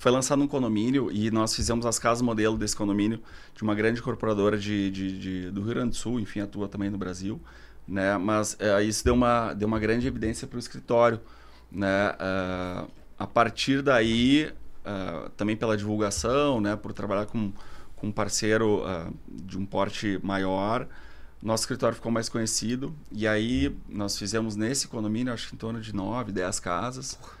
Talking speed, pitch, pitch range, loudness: 180 wpm, 105 Hz, 100-115 Hz, -27 LUFS